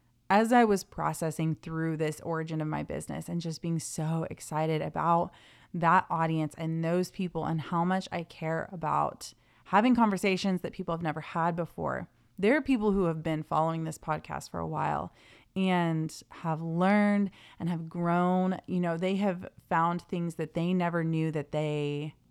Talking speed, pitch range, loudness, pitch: 175 wpm, 160-185 Hz, -30 LUFS, 170 Hz